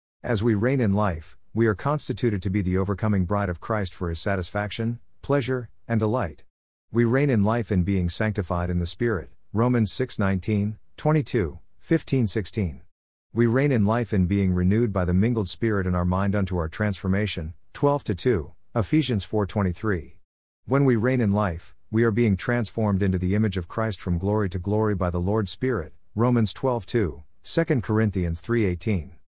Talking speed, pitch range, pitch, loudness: 170 wpm, 90-115 Hz, 105 Hz, -25 LUFS